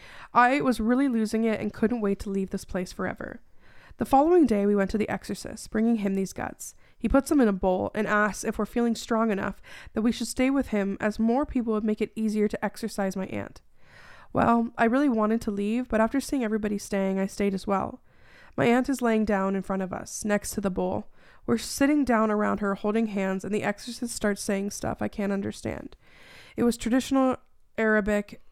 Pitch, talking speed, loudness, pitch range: 215 Hz, 215 wpm, -26 LUFS, 205-235 Hz